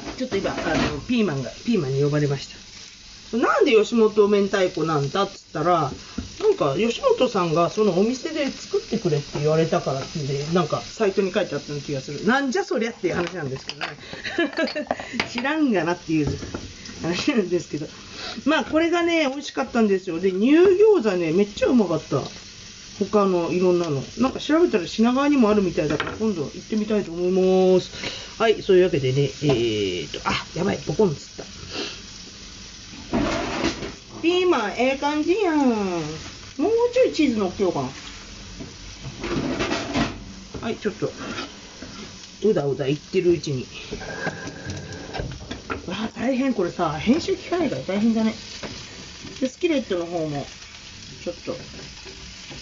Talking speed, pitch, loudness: 330 characters per minute, 190 Hz, -23 LUFS